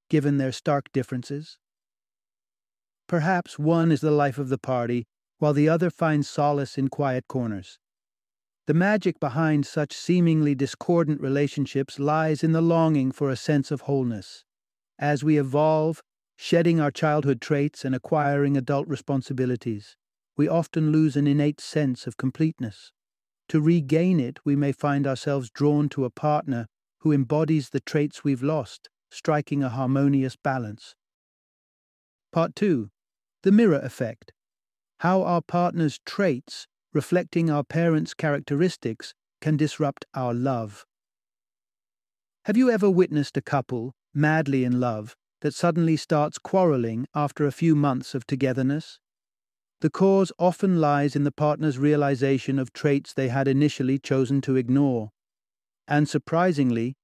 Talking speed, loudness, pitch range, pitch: 135 wpm, -24 LUFS, 130-155 Hz, 145 Hz